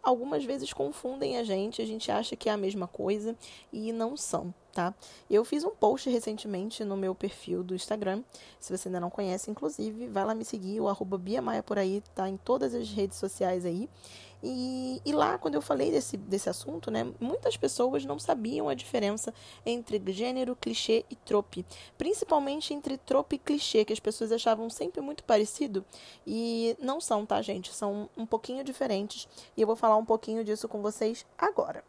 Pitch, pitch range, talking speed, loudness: 220 Hz, 195-245 Hz, 190 wpm, -31 LUFS